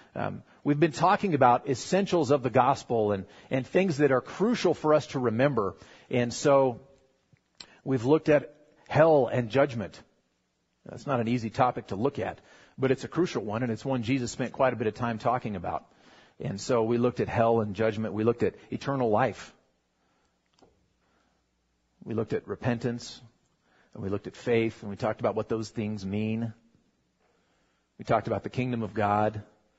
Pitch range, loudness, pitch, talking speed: 110-135 Hz, -28 LUFS, 120 Hz, 180 wpm